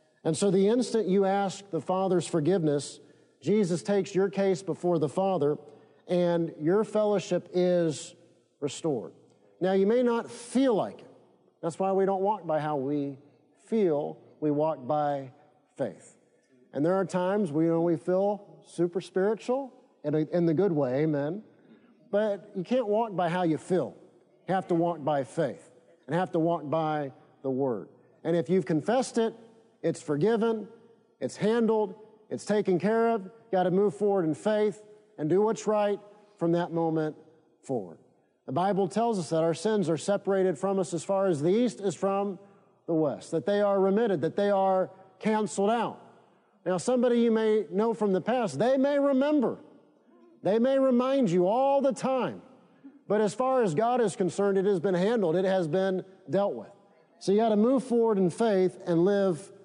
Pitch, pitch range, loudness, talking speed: 190 Hz, 165-215 Hz, -28 LUFS, 180 wpm